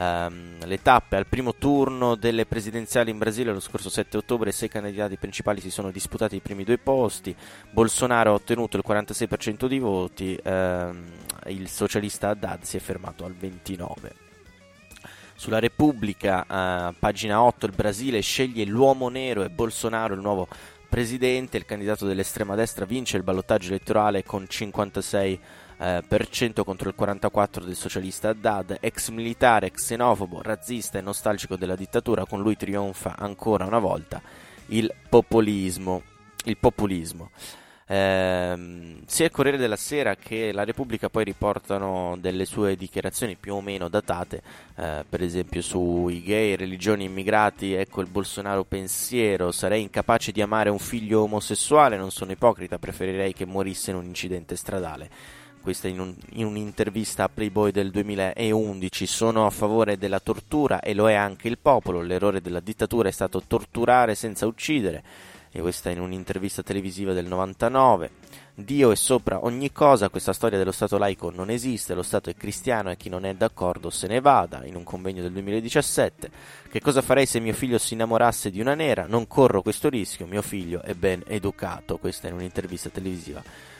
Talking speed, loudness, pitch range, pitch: 165 wpm, -25 LUFS, 95-110 Hz, 100 Hz